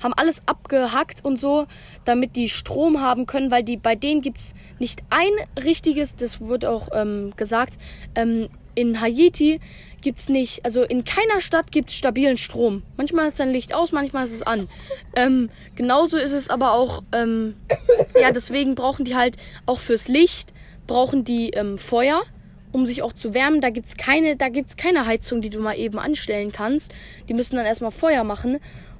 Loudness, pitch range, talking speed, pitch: -21 LUFS, 235-290 Hz, 190 wpm, 255 Hz